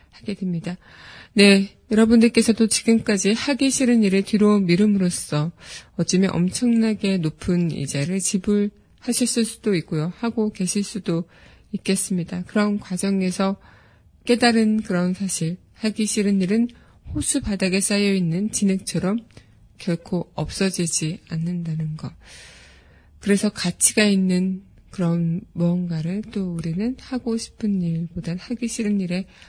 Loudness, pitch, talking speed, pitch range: -21 LUFS, 195 Hz, 280 characters per minute, 175-215 Hz